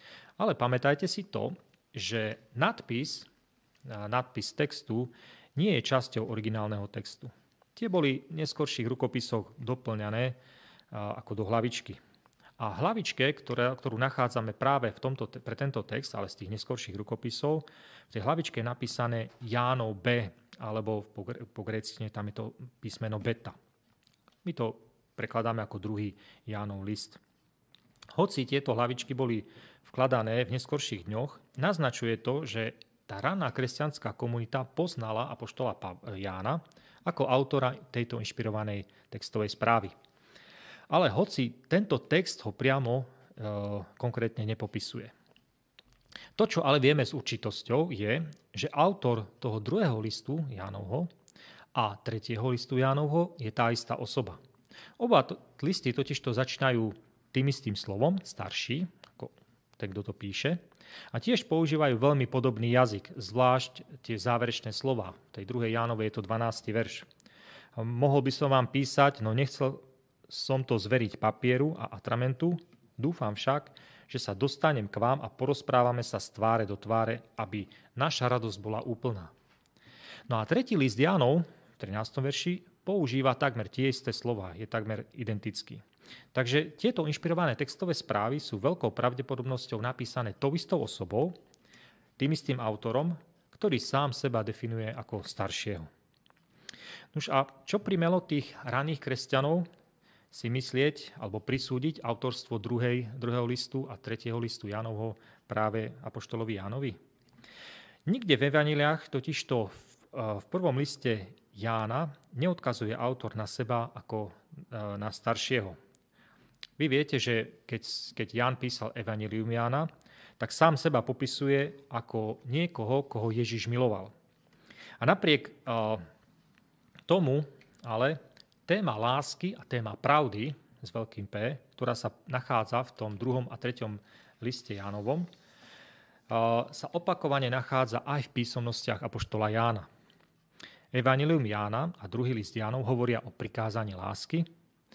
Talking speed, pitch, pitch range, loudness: 130 wpm, 125 Hz, 110-140 Hz, -32 LUFS